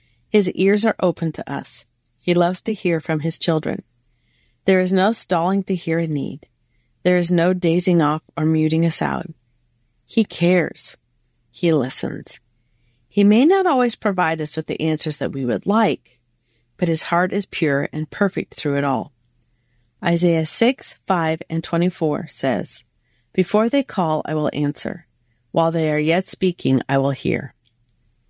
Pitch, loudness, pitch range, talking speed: 160 Hz, -20 LUFS, 125-180 Hz, 165 wpm